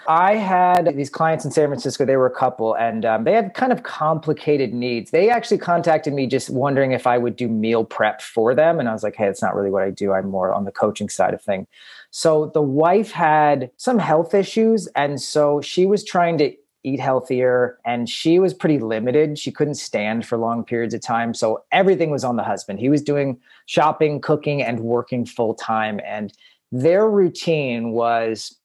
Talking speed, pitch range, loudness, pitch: 205 wpm, 115-160 Hz, -19 LUFS, 135 Hz